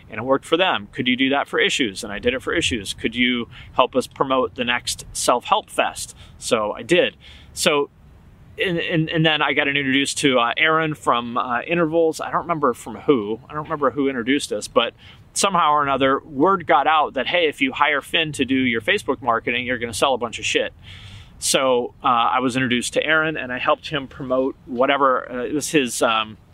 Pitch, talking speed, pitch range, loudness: 135 Hz, 220 wpm, 120-155 Hz, -20 LUFS